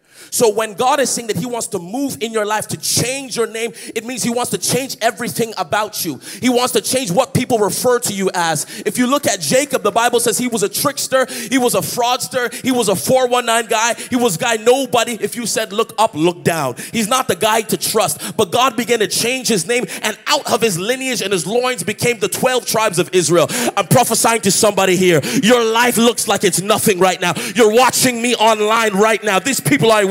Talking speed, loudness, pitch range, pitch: 235 wpm, -15 LUFS, 205-245 Hz, 230 Hz